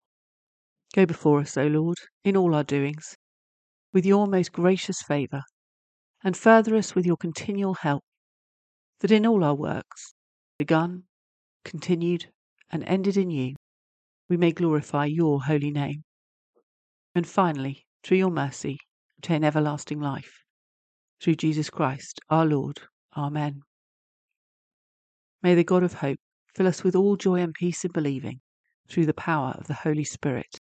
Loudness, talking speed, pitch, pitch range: -25 LUFS, 145 wpm, 155 Hz, 140-180 Hz